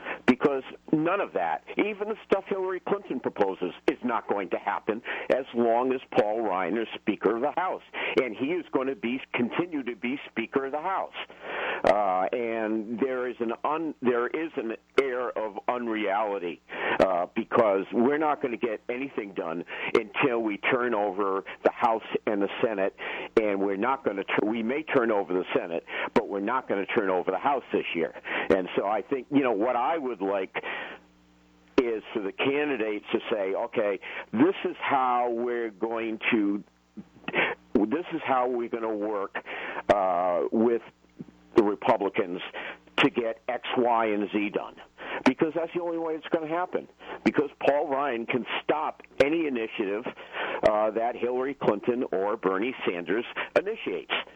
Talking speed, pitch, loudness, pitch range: 170 wpm, 120 Hz, -28 LUFS, 110-150 Hz